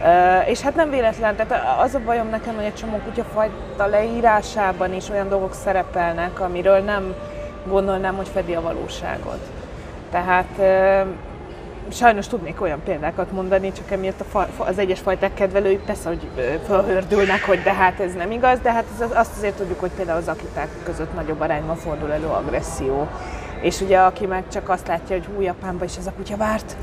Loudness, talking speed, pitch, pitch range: -21 LUFS, 175 wpm, 195 Hz, 185-210 Hz